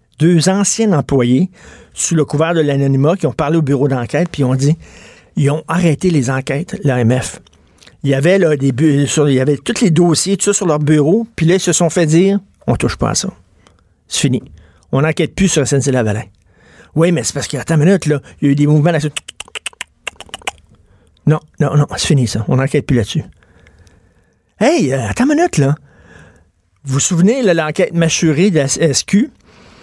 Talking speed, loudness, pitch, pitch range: 205 wpm, -14 LUFS, 150 Hz, 130-170 Hz